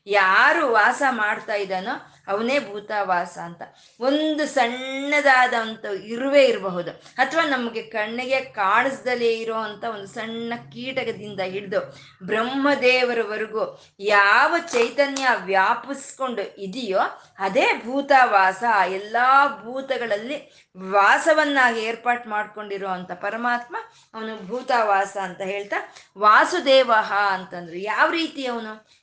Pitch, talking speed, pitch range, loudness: 230 Hz, 90 wpm, 200-260 Hz, -21 LUFS